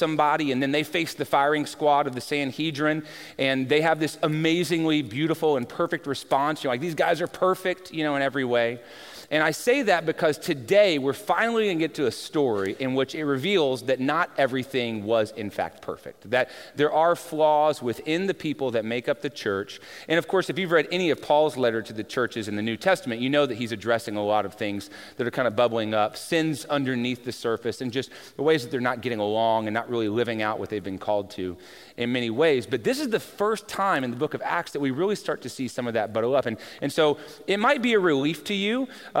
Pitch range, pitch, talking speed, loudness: 120-160 Hz, 145 Hz, 245 wpm, -25 LUFS